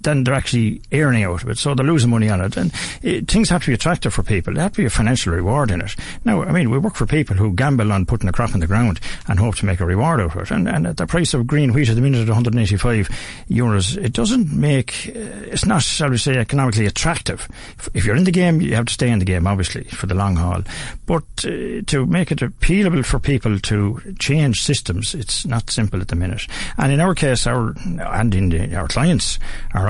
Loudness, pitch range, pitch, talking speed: -18 LUFS, 100-145 Hz, 120 Hz, 250 wpm